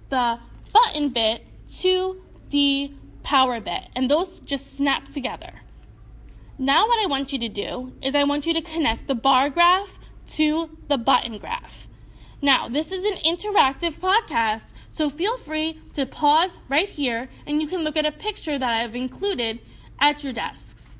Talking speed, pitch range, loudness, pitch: 170 wpm, 260-335 Hz, -23 LUFS, 290 Hz